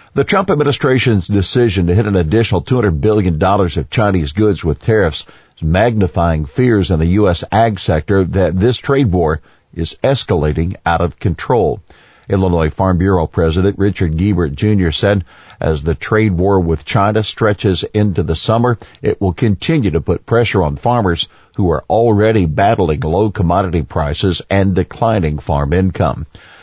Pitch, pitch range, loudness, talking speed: 95 Hz, 85-110 Hz, -14 LUFS, 155 wpm